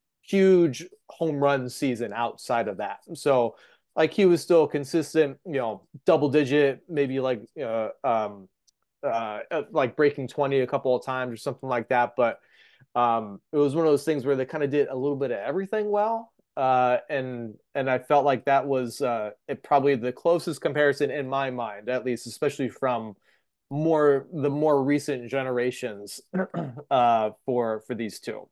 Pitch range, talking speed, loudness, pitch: 125-150 Hz, 175 wpm, -25 LUFS, 135 Hz